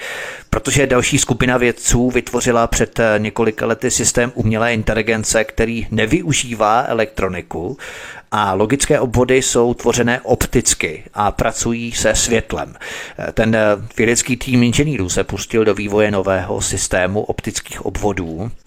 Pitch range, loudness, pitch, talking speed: 110-125 Hz, -16 LUFS, 115 Hz, 115 wpm